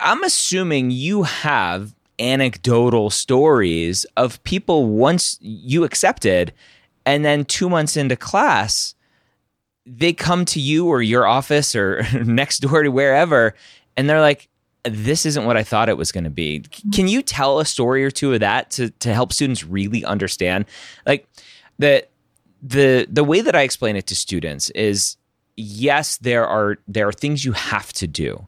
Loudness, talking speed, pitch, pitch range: -18 LUFS, 165 wpm, 130 Hz, 105-150 Hz